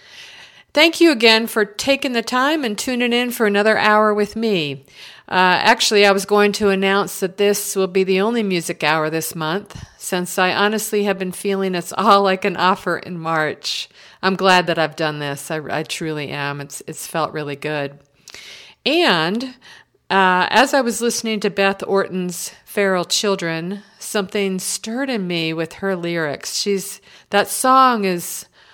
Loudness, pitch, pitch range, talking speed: -18 LUFS, 195 Hz, 170-215 Hz, 170 wpm